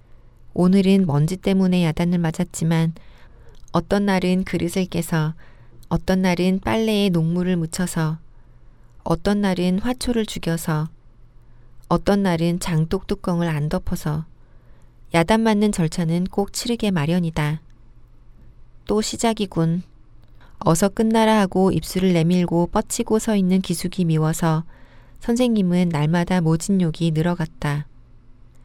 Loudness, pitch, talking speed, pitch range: -21 LUFS, 170 Hz, 250 characters per minute, 150-190 Hz